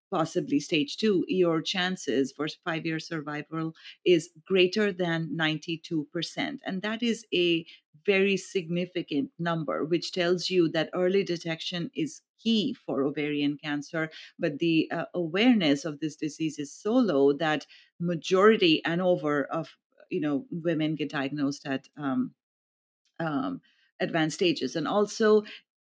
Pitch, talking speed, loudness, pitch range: 165 Hz, 135 wpm, -28 LUFS, 150-180 Hz